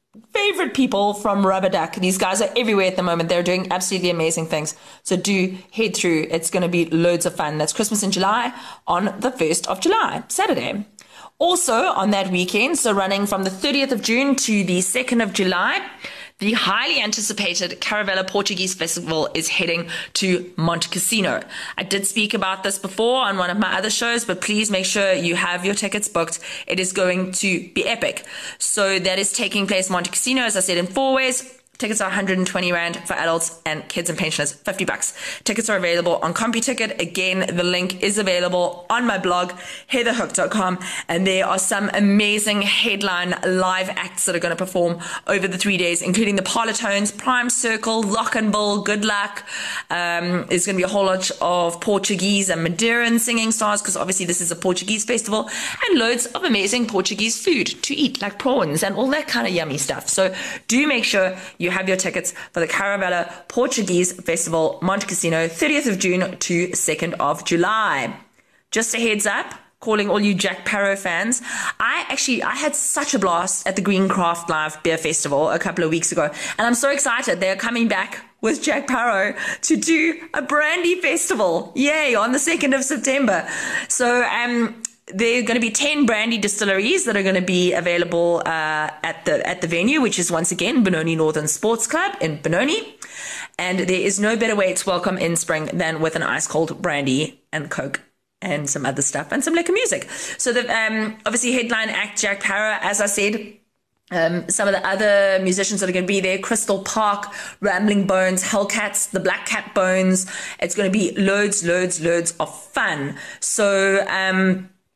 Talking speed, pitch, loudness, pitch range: 190 wpm, 195 Hz, -20 LUFS, 180-225 Hz